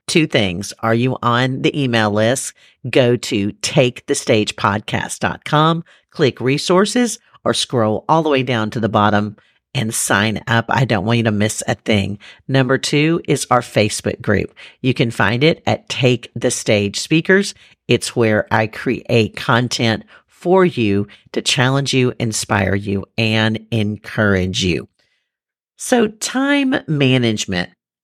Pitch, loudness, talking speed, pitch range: 115 Hz, -17 LUFS, 140 wpm, 105-135 Hz